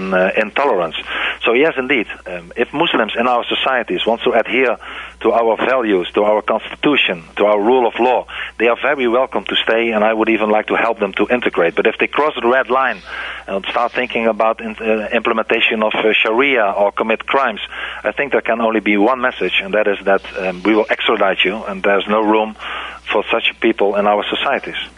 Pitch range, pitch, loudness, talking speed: 105-110 Hz, 110 Hz, -16 LUFS, 215 wpm